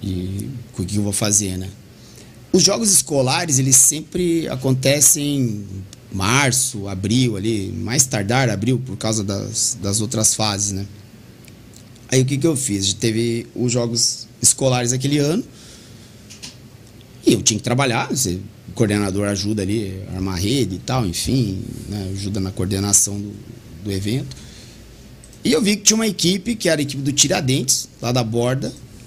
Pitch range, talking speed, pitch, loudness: 105-130 Hz, 155 wpm, 115 Hz, -18 LUFS